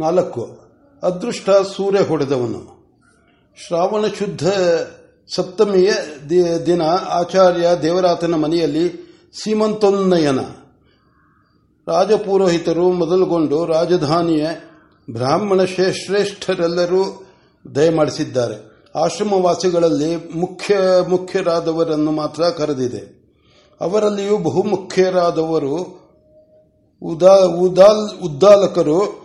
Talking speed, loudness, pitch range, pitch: 55 wpm, -16 LUFS, 165-195 Hz, 180 Hz